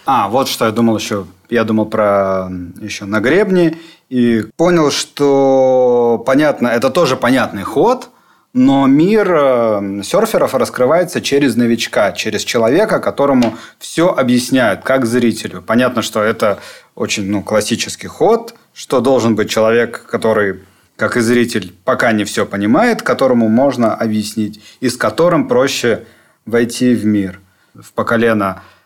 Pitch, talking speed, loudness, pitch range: 115 Hz, 135 wpm, -14 LUFS, 105-125 Hz